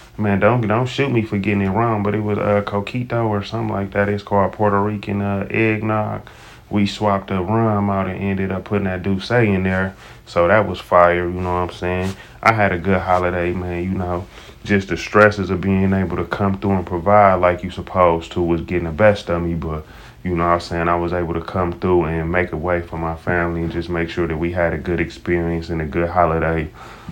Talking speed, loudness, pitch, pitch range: 240 wpm, -19 LUFS, 95 Hz, 85-105 Hz